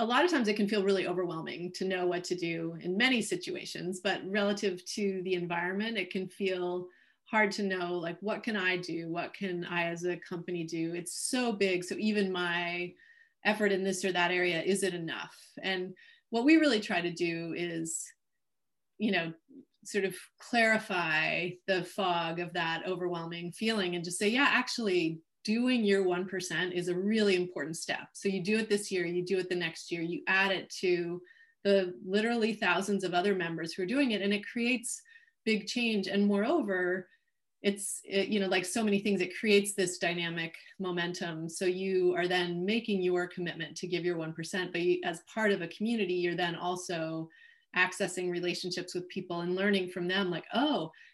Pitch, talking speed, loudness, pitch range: 185 Hz, 190 wpm, -31 LUFS, 175-205 Hz